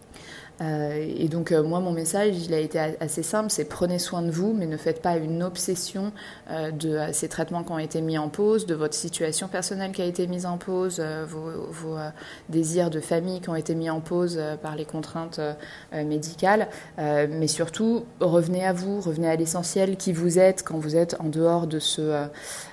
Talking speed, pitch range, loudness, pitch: 195 wpm, 155-185 Hz, -26 LUFS, 165 Hz